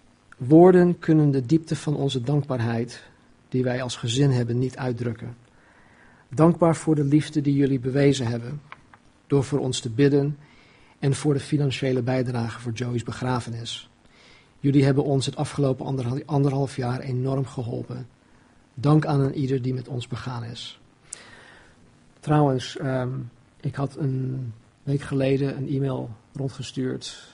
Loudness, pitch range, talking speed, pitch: -24 LUFS, 125-140 Hz, 135 wpm, 135 Hz